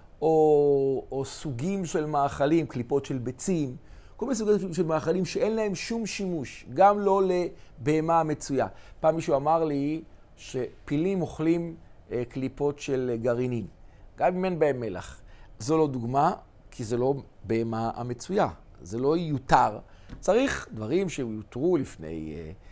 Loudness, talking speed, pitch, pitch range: -27 LUFS, 130 wpm, 140 Hz, 120-165 Hz